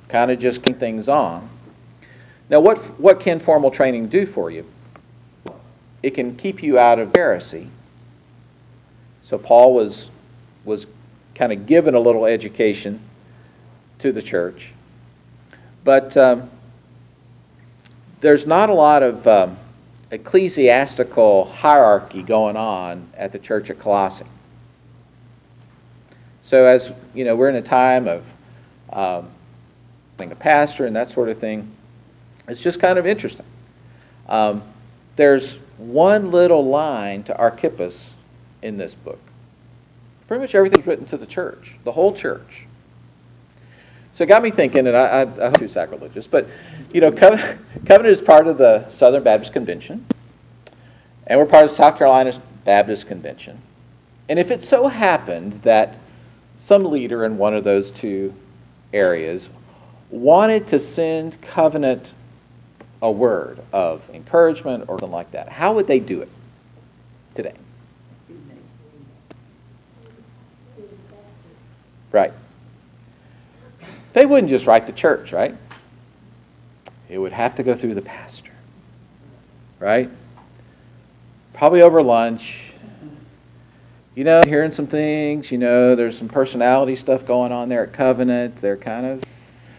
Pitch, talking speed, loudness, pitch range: 120 Hz, 130 wpm, -16 LUFS, 95-140 Hz